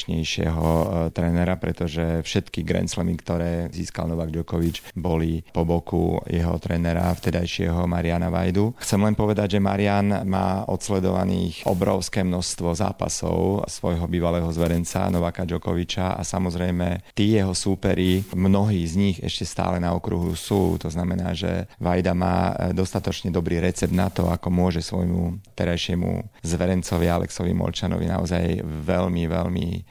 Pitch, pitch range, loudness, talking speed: 90 Hz, 85-95 Hz, -24 LUFS, 130 wpm